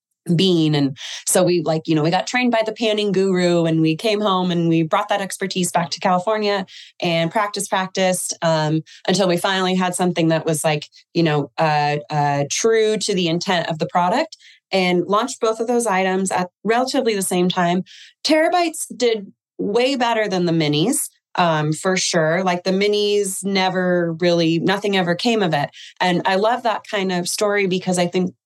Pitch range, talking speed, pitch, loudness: 170-205 Hz, 190 wpm, 185 Hz, -19 LUFS